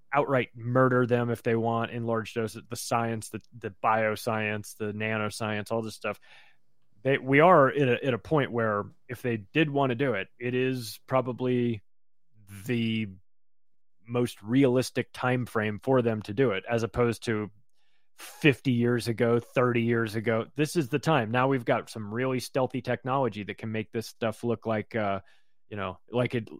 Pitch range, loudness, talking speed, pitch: 110-125 Hz, -28 LUFS, 180 wpm, 120 Hz